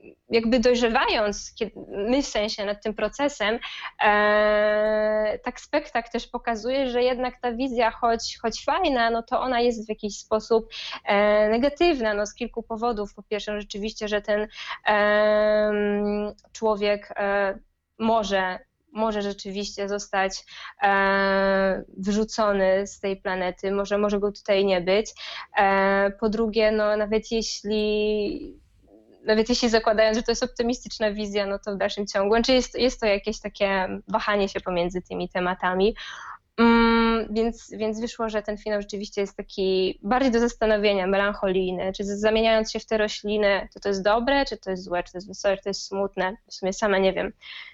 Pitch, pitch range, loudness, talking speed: 210 Hz, 200-230 Hz, -24 LUFS, 160 wpm